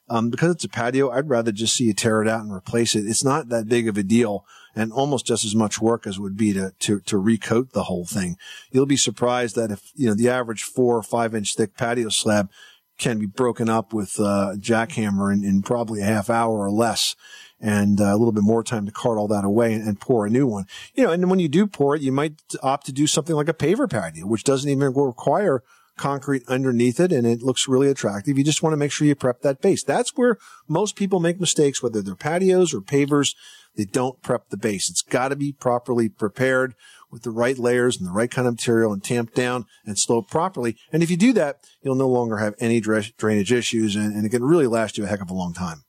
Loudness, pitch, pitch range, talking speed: -21 LUFS, 120 Hz, 110-135 Hz, 245 wpm